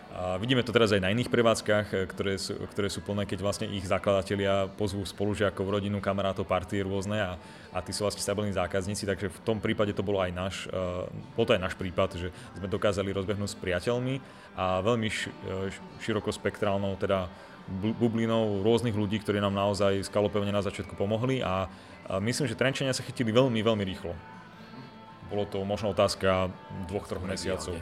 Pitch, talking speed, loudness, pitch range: 100 Hz, 170 wpm, -29 LUFS, 95-105 Hz